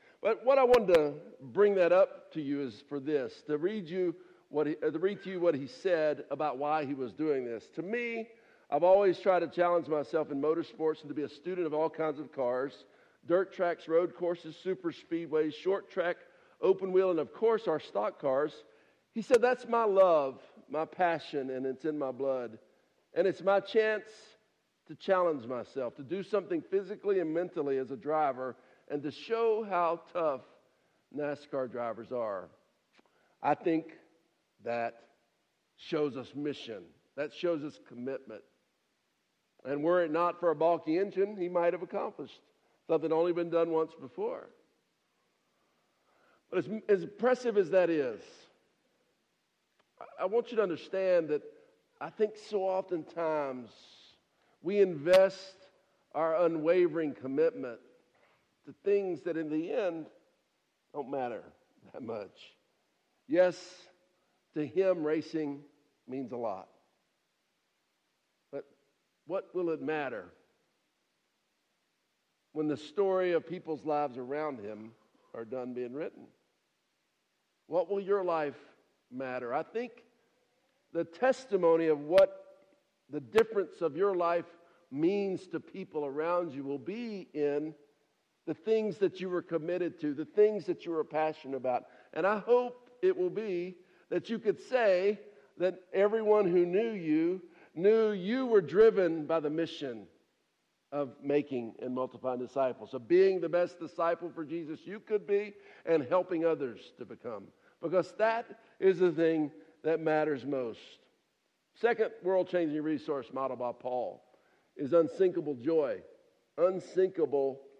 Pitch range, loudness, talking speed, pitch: 150-200 Hz, -32 LUFS, 145 wpm, 170 Hz